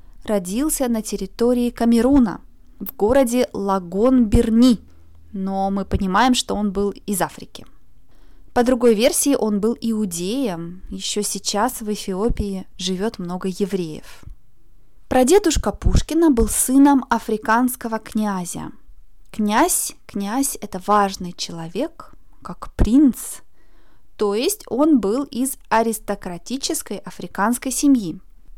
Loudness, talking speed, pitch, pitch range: -20 LUFS, 105 wpm, 220 Hz, 195-255 Hz